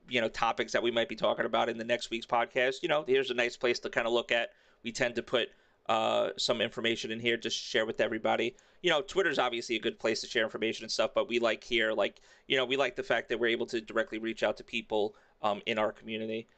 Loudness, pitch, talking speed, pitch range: -31 LUFS, 115 Hz, 270 wpm, 110-120 Hz